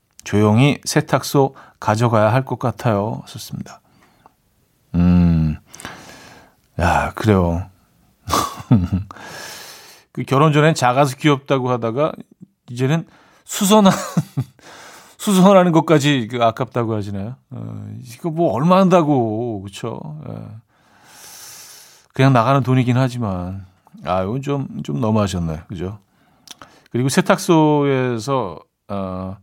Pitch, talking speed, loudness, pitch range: 125 Hz, 215 characters per minute, -17 LUFS, 105-150 Hz